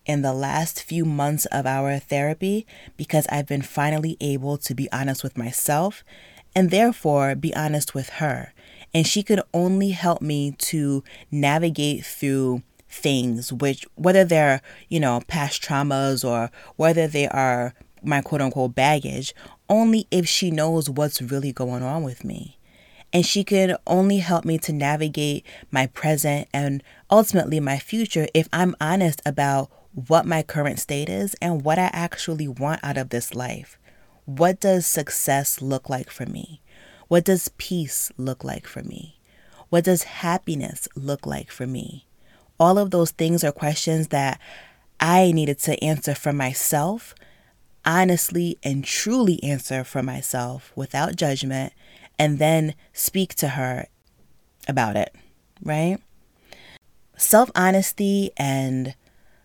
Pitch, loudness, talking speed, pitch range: 150 Hz, -22 LUFS, 145 wpm, 135-170 Hz